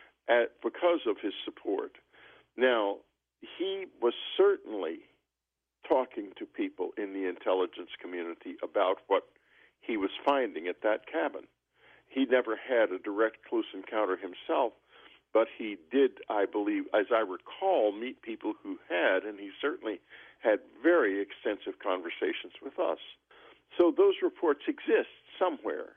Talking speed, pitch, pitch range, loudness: 135 wpm, 355 Hz, 295-410 Hz, -31 LUFS